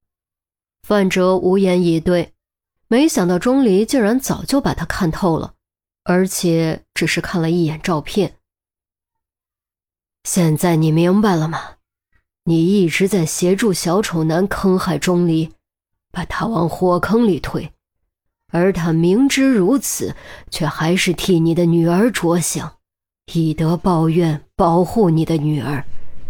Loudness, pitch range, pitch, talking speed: -17 LUFS, 160-190 Hz, 175 Hz, 190 characters per minute